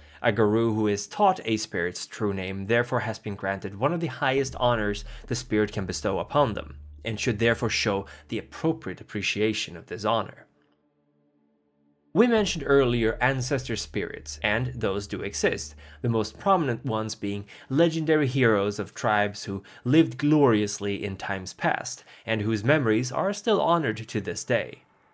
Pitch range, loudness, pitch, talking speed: 100-125 Hz, -26 LUFS, 110 Hz, 160 wpm